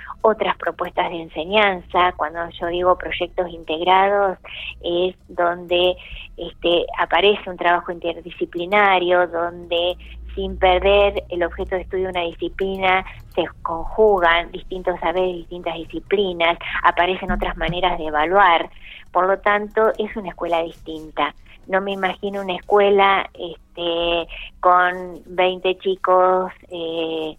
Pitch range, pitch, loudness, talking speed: 170-190 Hz, 180 Hz, -20 LUFS, 120 wpm